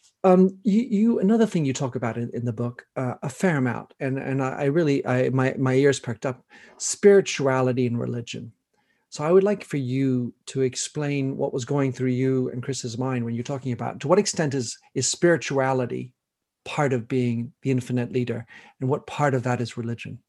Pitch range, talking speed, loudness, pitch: 125-145 Hz, 205 wpm, -24 LUFS, 130 Hz